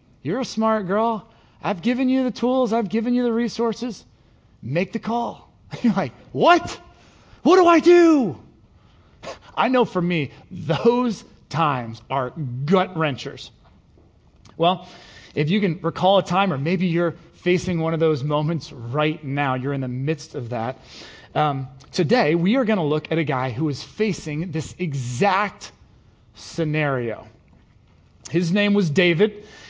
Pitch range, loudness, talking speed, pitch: 135-210 Hz, -21 LUFS, 155 wpm, 165 Hz